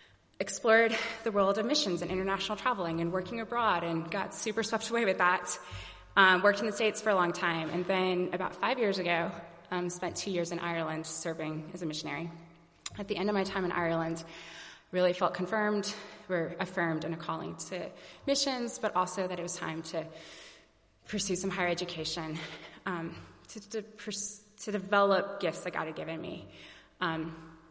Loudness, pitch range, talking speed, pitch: -32 LUFS, 170-210 Hz, 185 wpm, 180 Hz